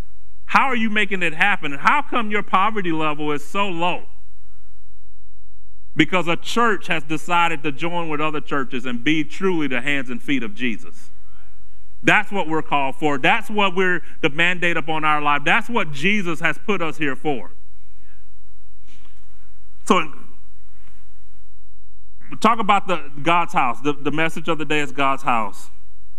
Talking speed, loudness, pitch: 160 wpm, -20 LUFS, 145 Hz